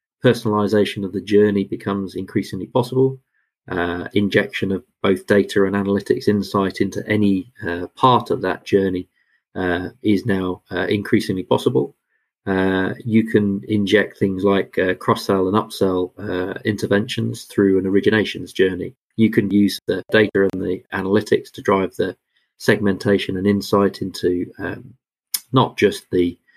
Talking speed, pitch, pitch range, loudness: 140 wpm, 100 Hz, 95-105 Hz, -20 LUFS